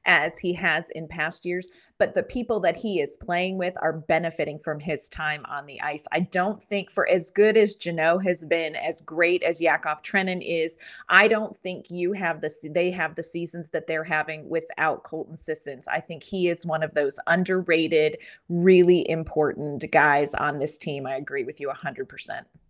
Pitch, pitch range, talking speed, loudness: 165 Hz, 155-180 Hz, 200 wpm, -24 LUFS